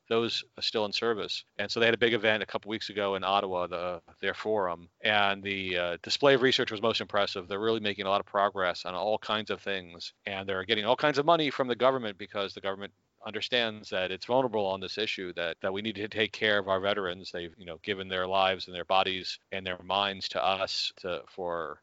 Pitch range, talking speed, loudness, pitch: 95-110 Hz, 245 wpm, -29 LUFS, 100 Hz